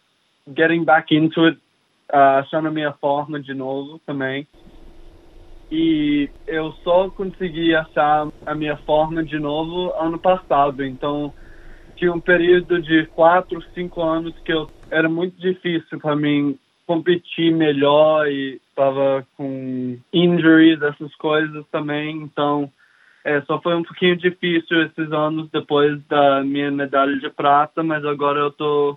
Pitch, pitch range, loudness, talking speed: 155 Hz, 145-165 Hz, -19 LUFS, 140 wpm